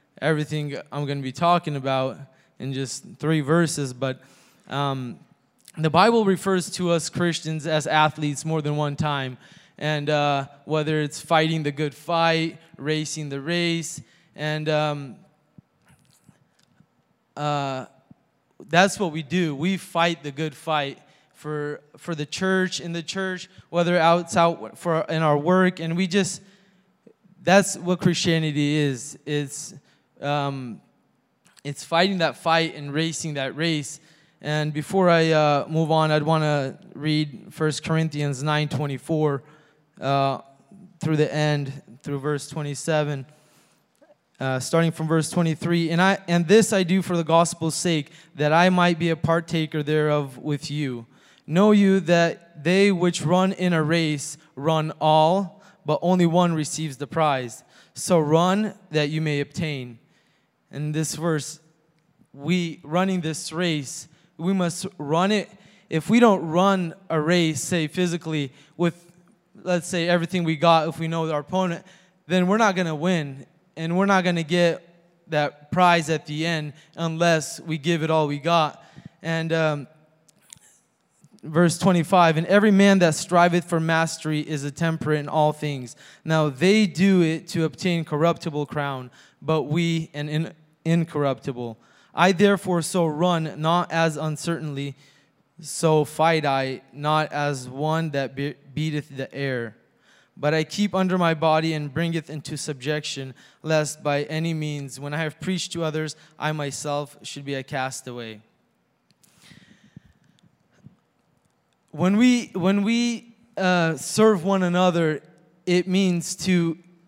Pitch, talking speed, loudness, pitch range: 160 Hz, 145 wpm, -23 LUFS, 150-175 Hz